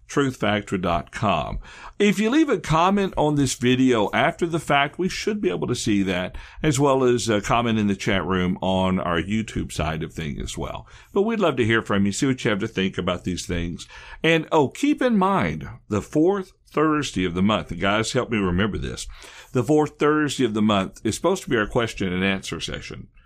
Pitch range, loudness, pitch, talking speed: 95-150 Hz, -22 LUFS, 115 Hz, 215 wpm